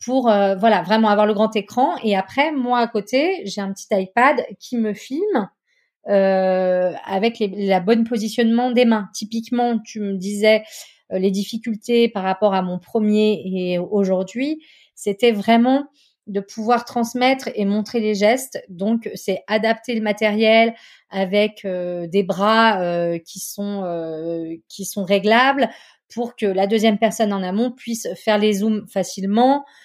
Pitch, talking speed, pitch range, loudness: 215 Hz, 160 wpm, 195-235 Hz, -19 LUFS